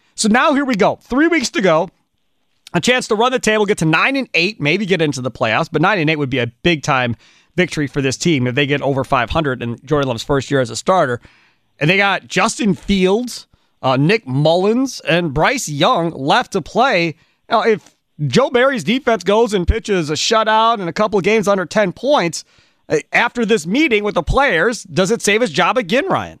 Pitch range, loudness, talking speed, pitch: 150-225 Hz, -16 LUFS, 220 wpm, 185 Hz